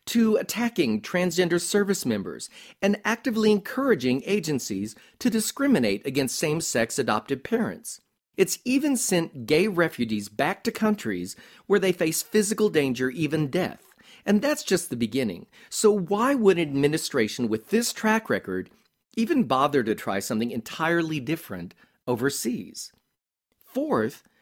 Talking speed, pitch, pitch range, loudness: 130 wpm, 190 Hz, 145-220 Hz, -25 LUFS